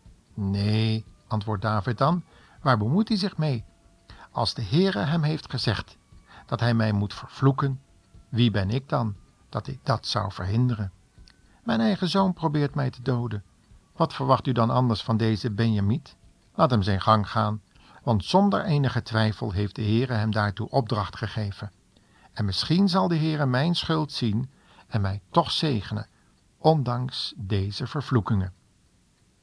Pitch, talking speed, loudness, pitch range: 115 Hz, 155 wpm, -25 LUFS, 105-140 Hz